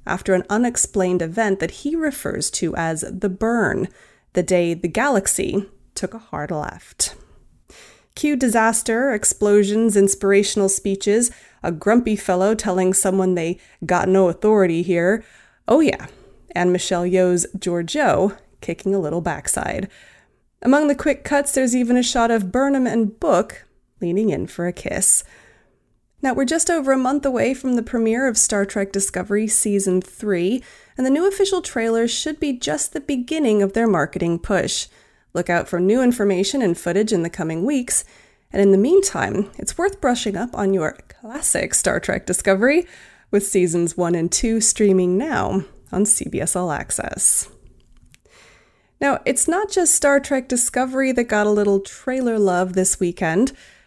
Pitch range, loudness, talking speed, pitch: 185-250 Hz, -19 LUFS, 160 wpm, 205 Hz